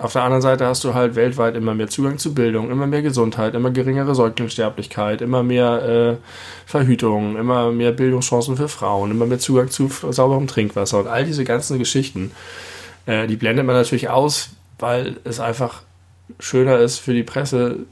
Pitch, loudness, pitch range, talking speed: 120 Hz, -19 LUFS, 115-130 Hz, 180 wpm